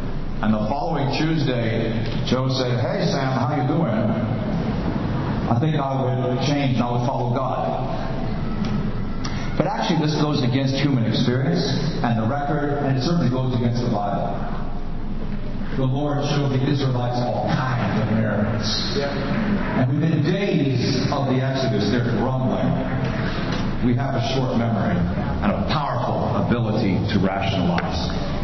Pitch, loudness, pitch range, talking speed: 130 Hz, -22 LUFS, 115-140 Hz, 140 wpm